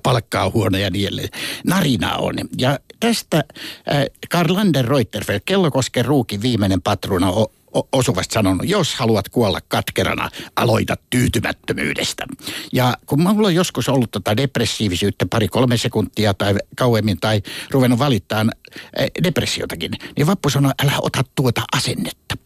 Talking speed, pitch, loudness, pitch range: 135 wpm, 120 Hz, -19 LUFS, 105-140 Hz